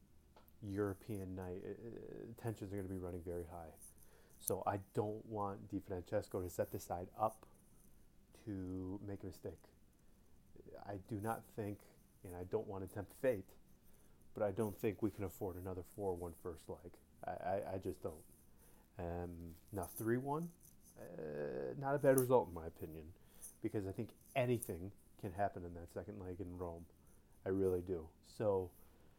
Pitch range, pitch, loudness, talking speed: 85-105 Hz, 95 Hz, -43 LUFS, 165 wpm